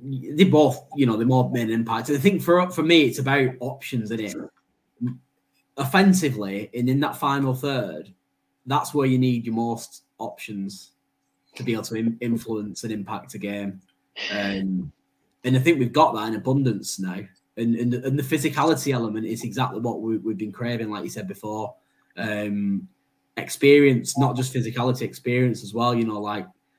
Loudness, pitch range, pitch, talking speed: -23 LUFS, 100-130 Hz, 115 Hz, 180 wpm